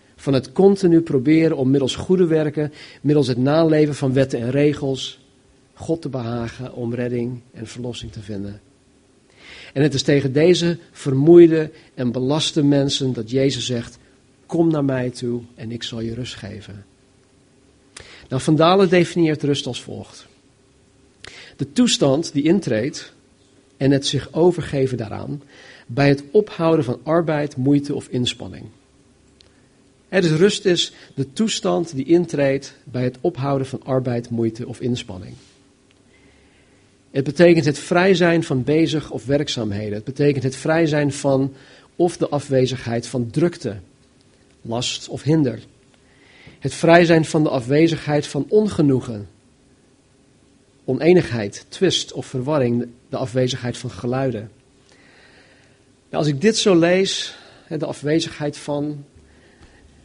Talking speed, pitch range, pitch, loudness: 135 wpm, 125-155 Hz, 135 Hz, -19 LUFS